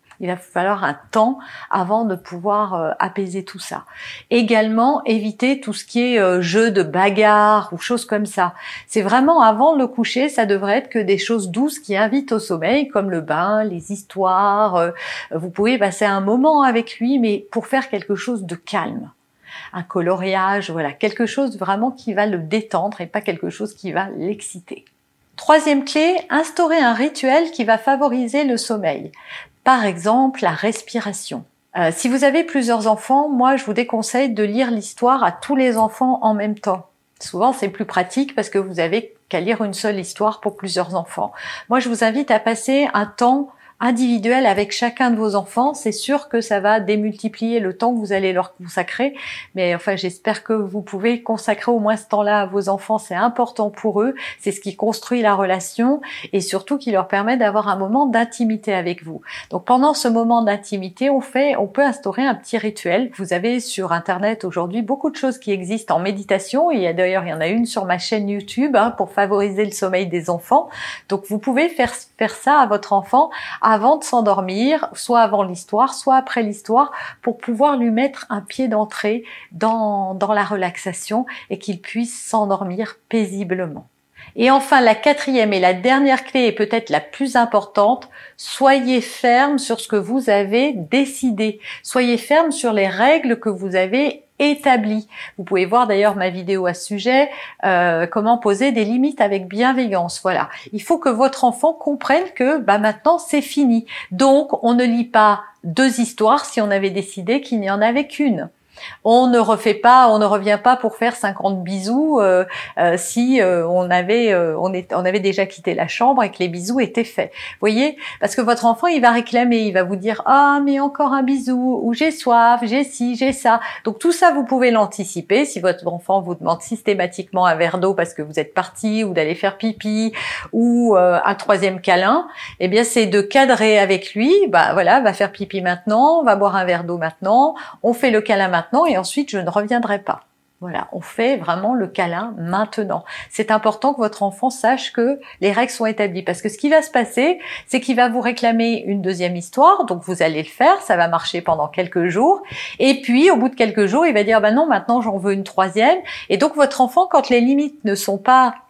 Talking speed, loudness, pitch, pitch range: 200 wpm, -17 LUFS, 220 Hz, 195-255 Hz